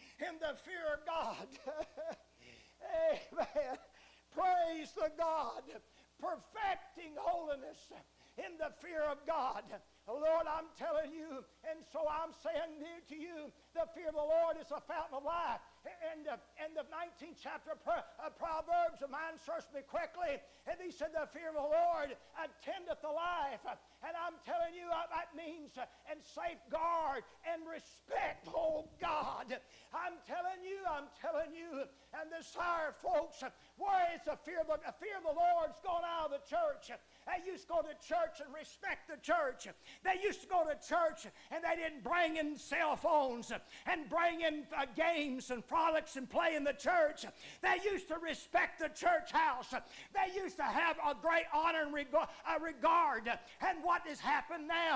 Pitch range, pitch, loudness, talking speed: 300-335 Hz, 320 Hz, -39 LUFS, 175 wpm